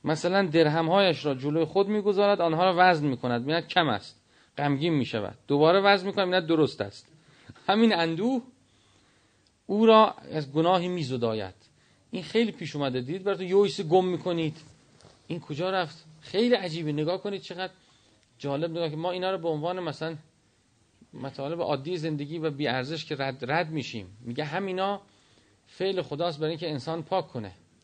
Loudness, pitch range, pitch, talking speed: -27 LUFS, 140-185 Hz, 165 Hz, 170 wpm